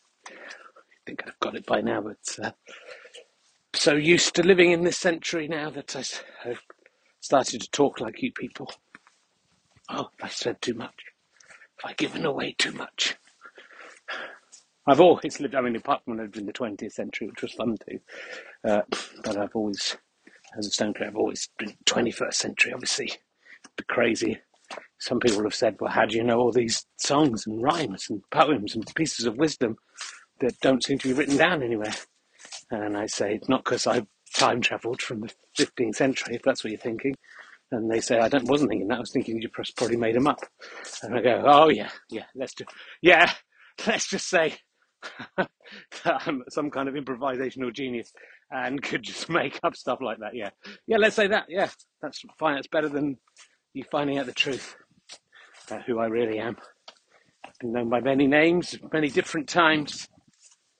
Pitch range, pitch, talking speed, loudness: 115-160 Hz, 135 Hz, 190 wpm, -25 LUFS